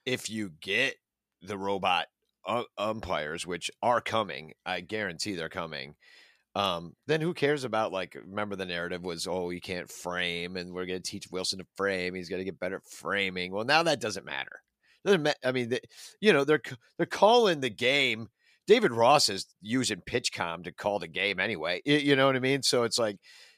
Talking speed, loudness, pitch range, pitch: 200 wpm, -29 LUFS, 90-130 Hz, 100 Hz